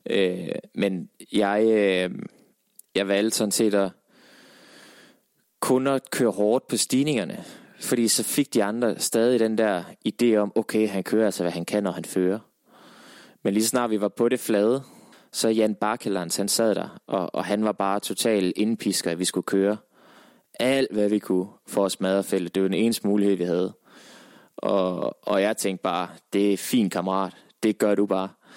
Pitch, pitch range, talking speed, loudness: 105 Hz, 95-115 Hz, 180 wpm, -24 LUFS